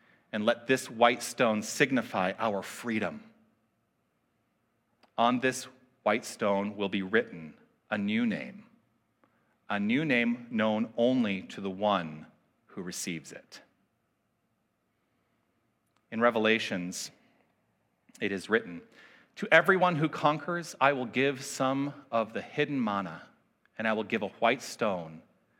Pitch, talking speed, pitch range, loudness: 115 Hz, 125 wpm, 105-145 Hz, -29 LUFS